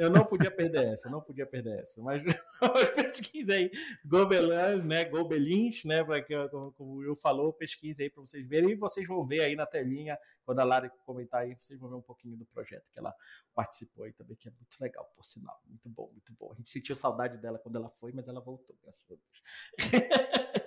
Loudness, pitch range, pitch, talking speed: -31 LUFS, 125-165 Hz, 140 Hz, 220 wpm